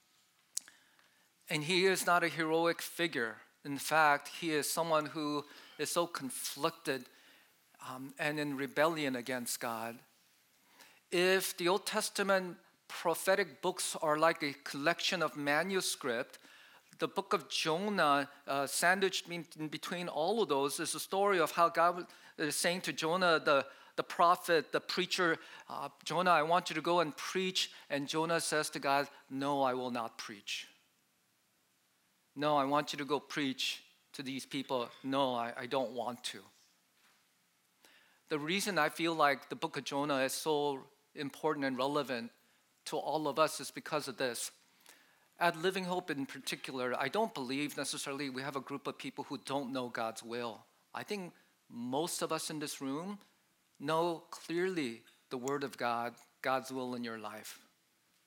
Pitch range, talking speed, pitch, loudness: 140-170 Hz, 160 wpm, 150 Hz, -35 LUFS